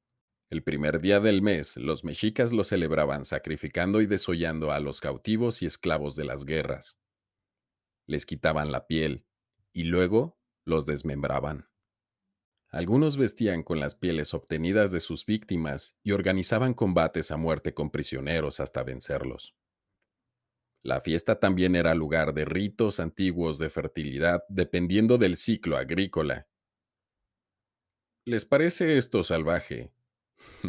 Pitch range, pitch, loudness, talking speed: 80-105 Hz, 90 Hz, -27 LUFS, 125 wpm